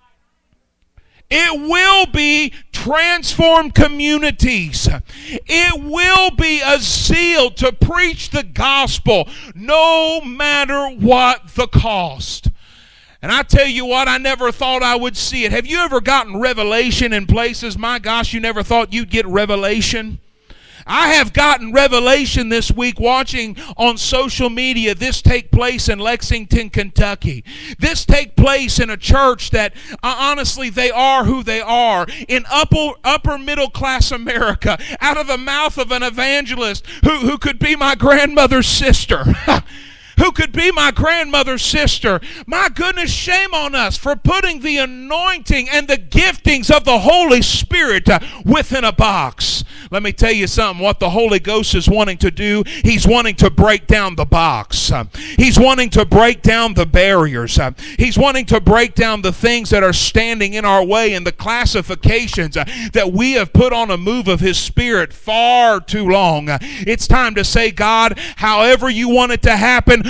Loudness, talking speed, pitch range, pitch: -14 LUFS, 160 wpm, 225-280 Hz, 250 Hz